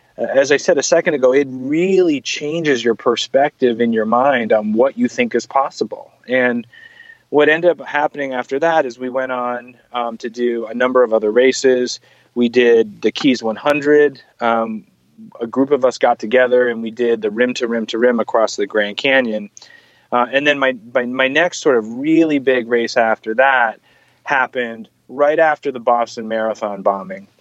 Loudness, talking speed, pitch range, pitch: -16 LUFS, 185 wpm, 115-145 Hz, 125 Hz